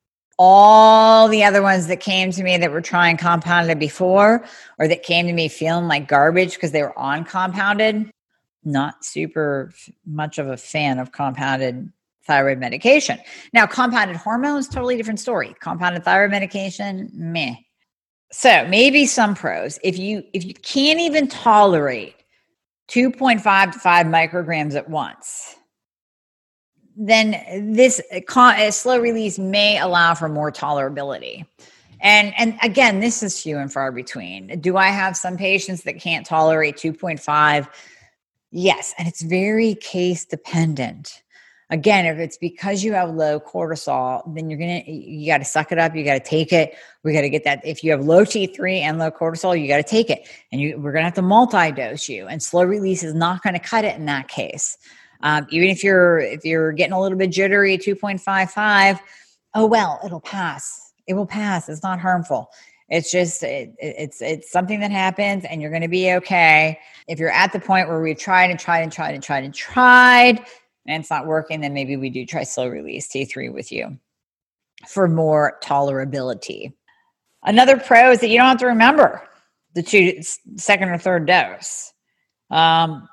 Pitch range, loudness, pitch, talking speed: 155-205 Hz, -17 LUFS, 180 Hz, 180 wpm